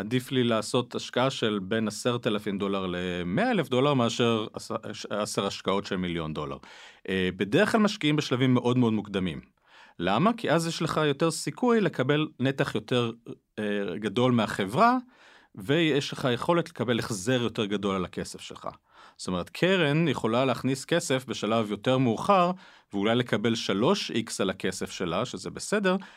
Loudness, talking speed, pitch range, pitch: -27 LUFS, 145 wpm, 105-150 Hz, 125 Hz